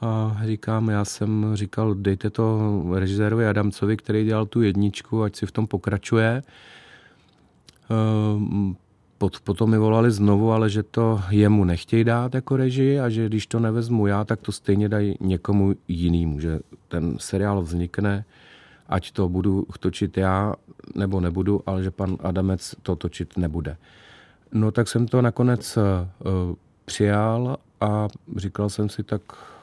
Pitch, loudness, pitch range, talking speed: 105 Hz, -23 LUFS, 95-110 Hz, 145 wpm